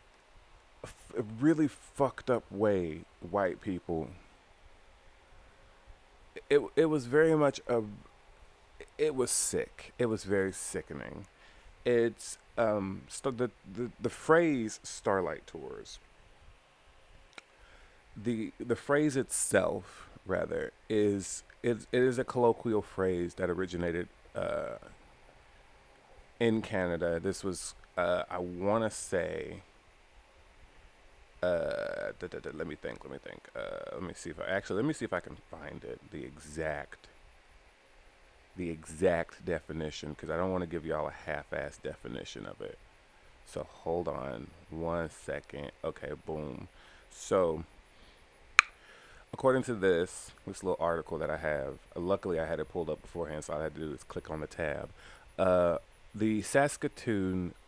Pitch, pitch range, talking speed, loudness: 90 Hz, 70-115 Hz, 140 wpm, -33 LUFS